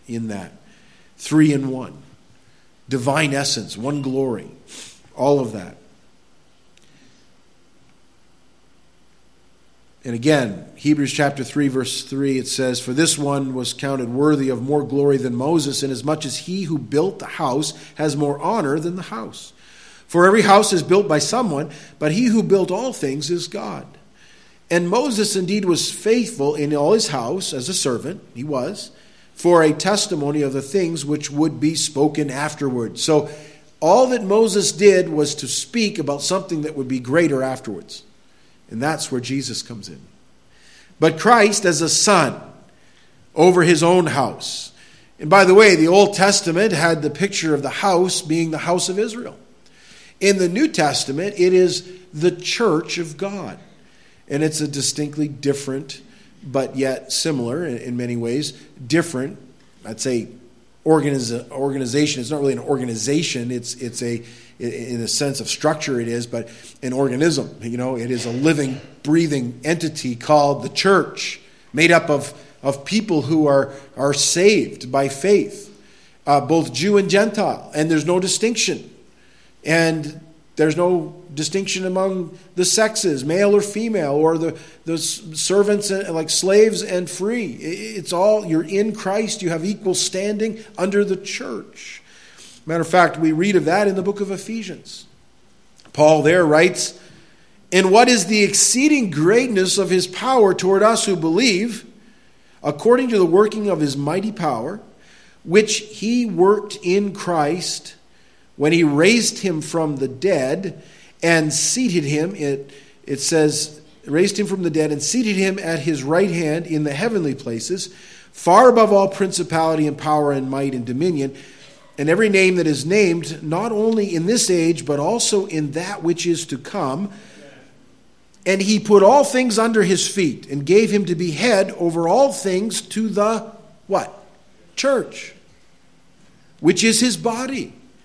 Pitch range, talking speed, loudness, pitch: 140-195 Hz, 155 wpm, -18 LUFS, 165 Hz